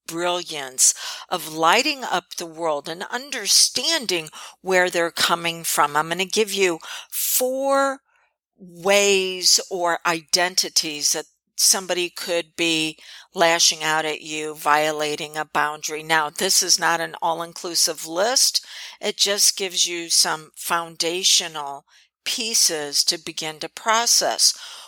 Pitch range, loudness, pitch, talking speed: 155-190 Hz, -20 LUFS, 170 Hz, 125 wpm